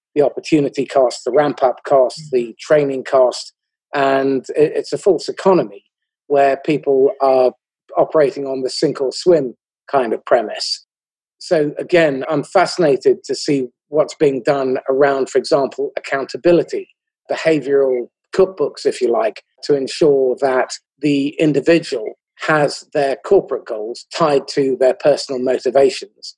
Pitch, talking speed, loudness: 145 Hz, 135 wpm, -17 LUFS